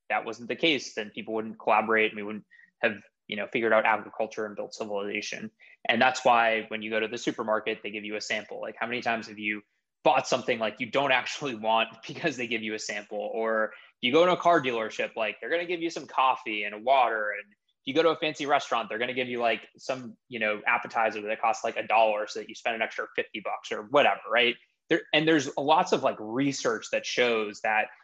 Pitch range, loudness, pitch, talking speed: 110-135 Hz, -27 LUFS, 115 Hz, 245 wpm